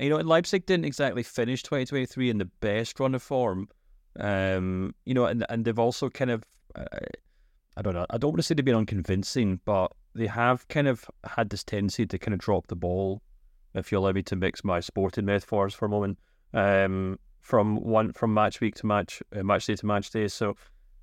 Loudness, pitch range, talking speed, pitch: -28 LUFS, 95-120 Hz, 215 wpm, 105 Hz